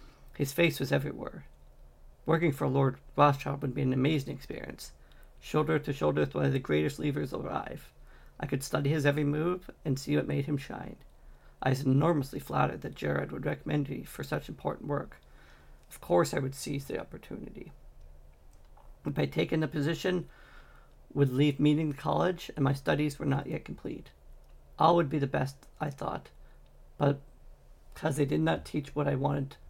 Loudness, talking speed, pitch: -31 LUFS, 180 wpm, 140 Hz